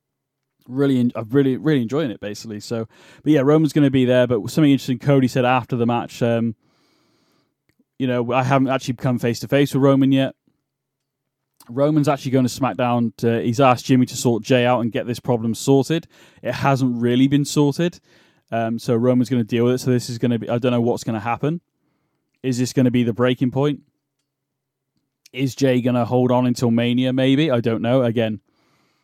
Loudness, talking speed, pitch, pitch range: -19 LUFS, 210 wpm, 130 Hz, 120-135 Hz